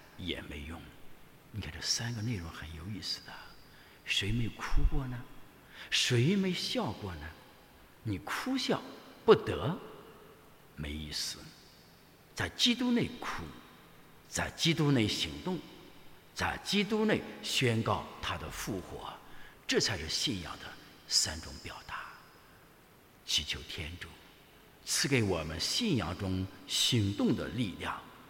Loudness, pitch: -33 LUFS, 110 Hz